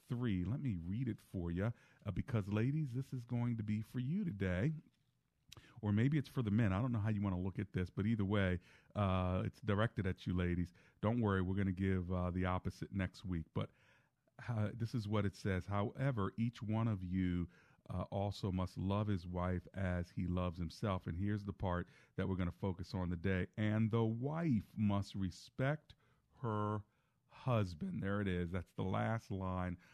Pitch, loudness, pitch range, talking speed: 100 Hz, -40 LUFS, 95-115 Hz, 200 wpm